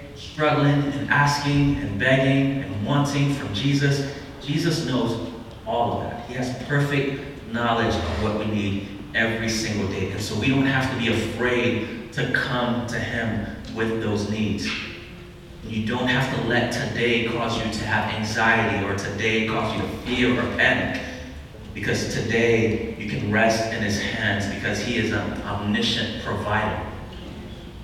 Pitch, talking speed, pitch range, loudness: 115 Hz, 155 wpm, 110-125 Hz, -23 LUFS